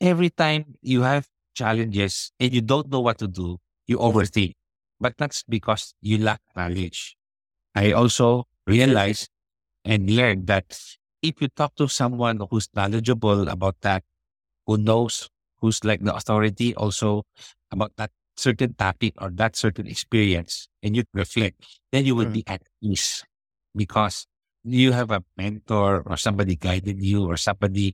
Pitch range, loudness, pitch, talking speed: 100-120 Hz, -23 LUFS, 110 Hz, 150 wpm